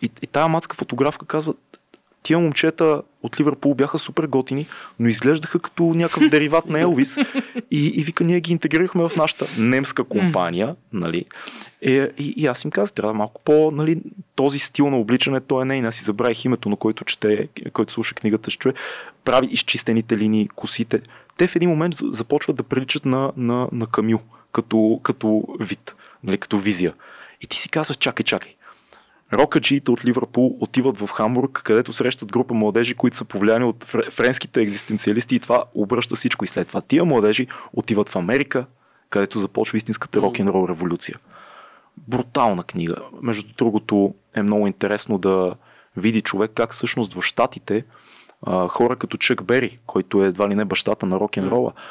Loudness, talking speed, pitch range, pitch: -20 LUFS, 170 wpm, 110-145 Hz, 120 Hz